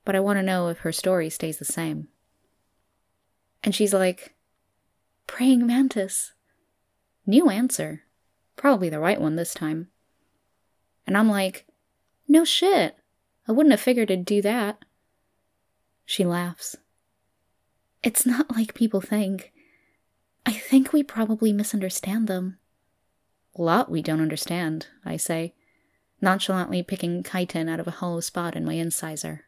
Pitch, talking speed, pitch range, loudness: 185 Hz, 135 wpm, 160-220 Hz, -24 LUFS